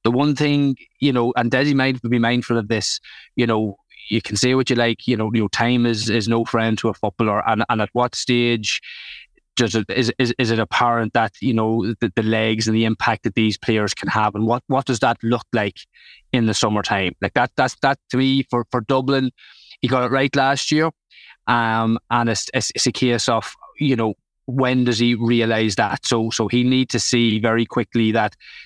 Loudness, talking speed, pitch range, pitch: -19 LUFS, 220 wpm, 110-125 Hz, 120 Hz